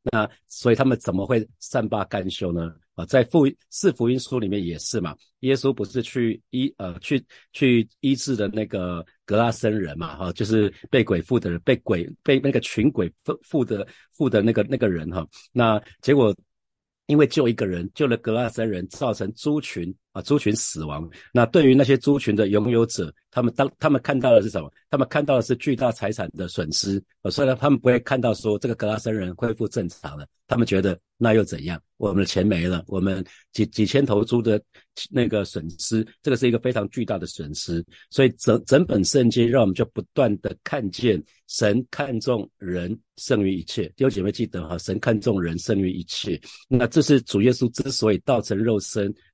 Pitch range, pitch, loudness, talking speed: 95-125 Hz, 110 Hz, -23 LUFS, 295 characters per minute